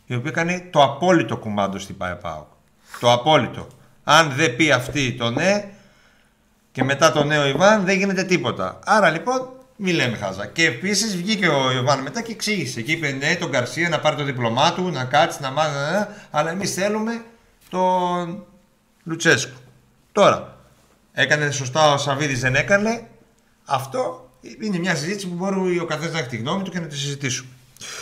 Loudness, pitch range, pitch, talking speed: -20 LUFS, 130-185 Hz, 155 Hz, 170 wpm